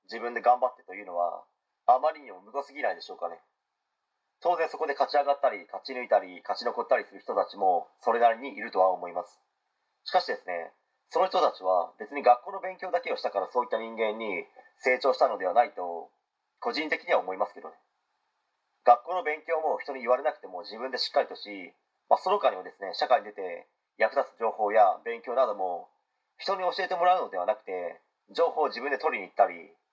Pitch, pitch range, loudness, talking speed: 145 Hz, 120-185 Hz, -28 LUFS, 410 characters per minute